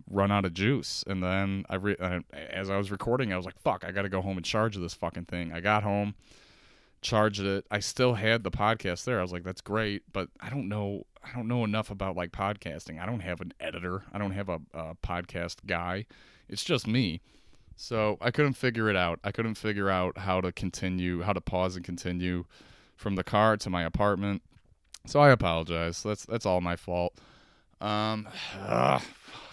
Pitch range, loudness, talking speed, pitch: 90-105 Hz, -30 LUFS, 210 wpm, 95 Hz